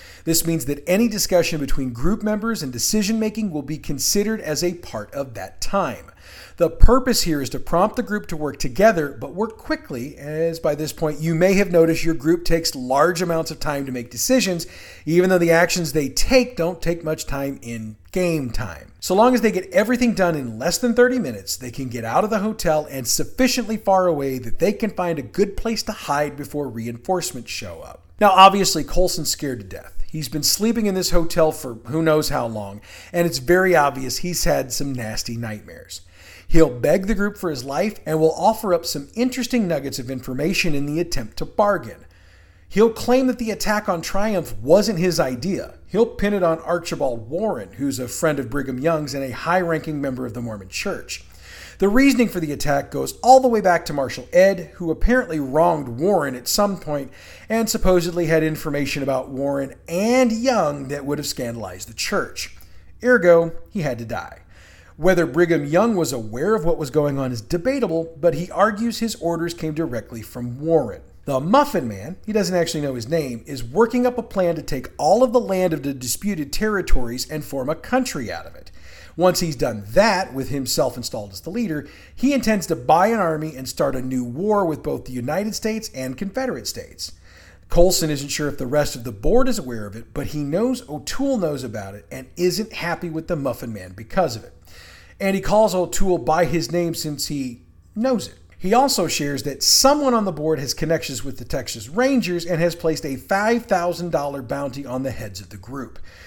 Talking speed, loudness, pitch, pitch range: 205 wpm, -21 LUFS, 160 Hz, 130-190 Hz